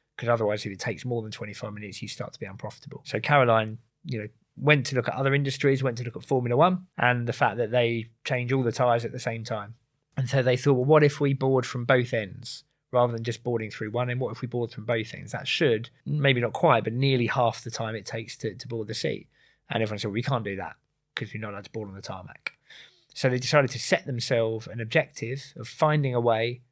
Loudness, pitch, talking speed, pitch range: -26 LUFS, 120 Hz, 260 wpm, 115-135 Hz